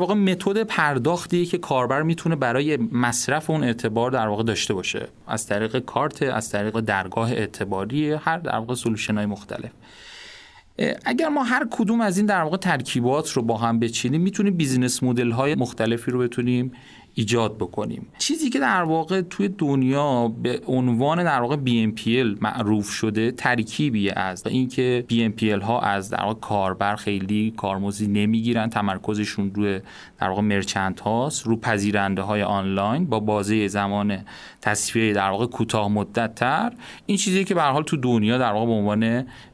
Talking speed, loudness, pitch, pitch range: 160 wpm, -23 LUFS, 120 Hz, 105-150 Hz